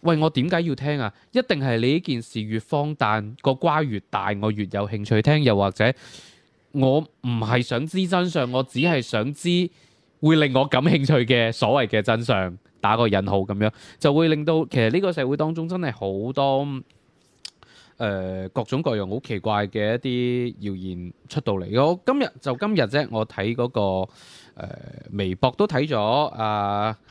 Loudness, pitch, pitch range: -23 LUFS, 125 Hz, 105-150 Hz